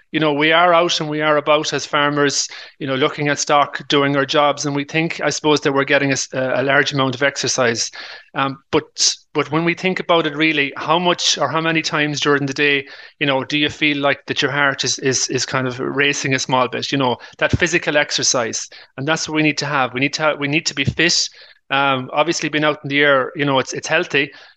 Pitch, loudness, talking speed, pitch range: 145 Hz, -17 LUFS, 250 wpm, 140-155 Hz